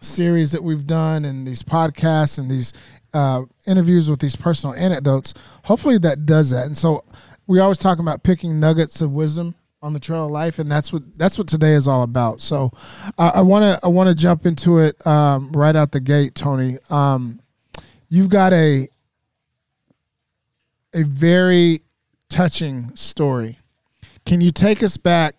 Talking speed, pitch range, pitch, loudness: 175 wpm, 140-175 Hz, 155 Hz, -17 LUFS